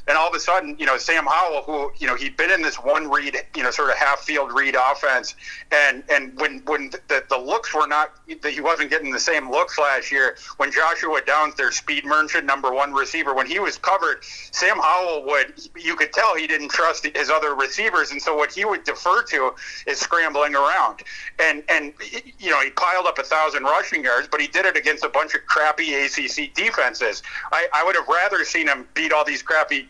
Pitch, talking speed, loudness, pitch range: 155 Hz, 220 wpm, -20 LUFS, 150-190 Hz